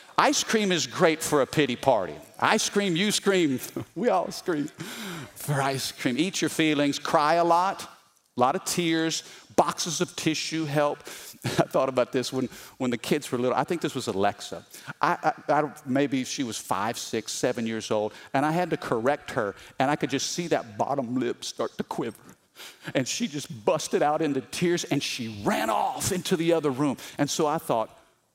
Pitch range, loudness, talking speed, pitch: 130-170 Hz, -26 LUFS, 200 wpm, 150 Hz